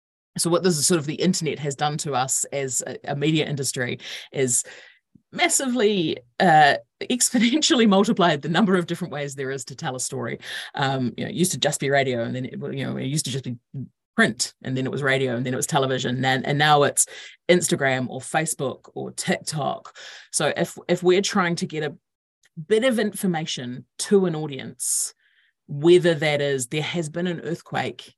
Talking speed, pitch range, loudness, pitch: 200 wpm, 130-175 Hz, -22 LUFS, 150 Hz